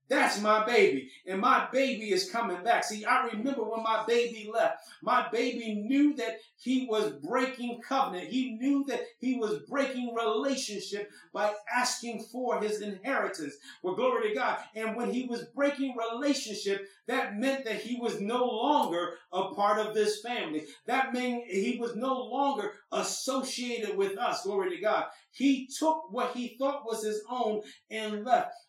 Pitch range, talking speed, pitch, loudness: 215-260 Hz, 165 wpm, 235 Hz, -30 LUFS